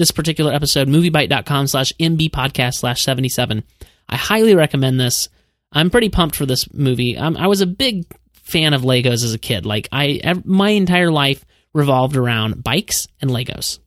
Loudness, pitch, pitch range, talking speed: -16 LUFS, 140 Hz, 125-165 Hz, 175 wpm